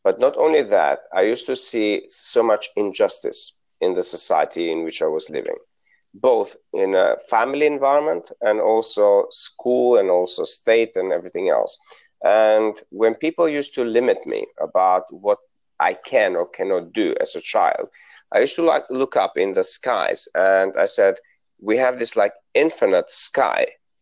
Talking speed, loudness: 170 wpm, -20 LUFS